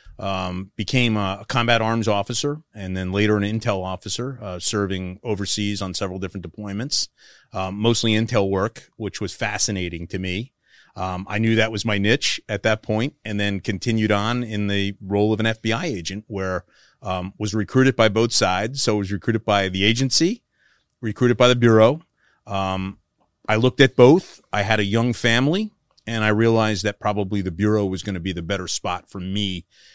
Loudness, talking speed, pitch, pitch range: -21 LUFS, 190 wpm, 105 Hz, 95-115 Hz